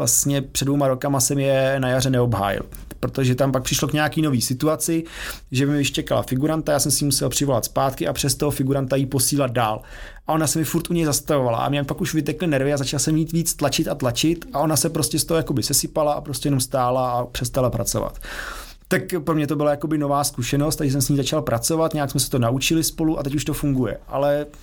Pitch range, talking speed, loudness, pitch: 135-155 Hz, 235 wpm, -21 LUFS, 145 Hz